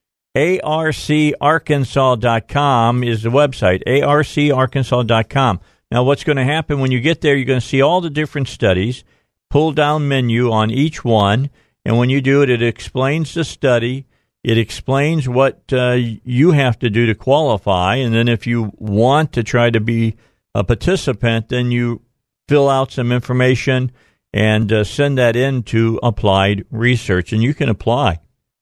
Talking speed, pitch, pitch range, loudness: 160 wpm, 125 Hz, 115-140 Hz, -16 LUFS